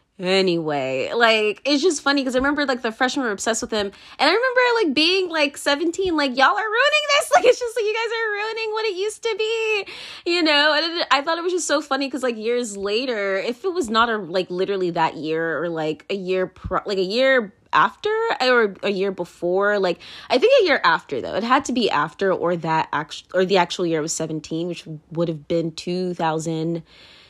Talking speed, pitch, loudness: 230 wpm, 235 Hz, -20 LUFS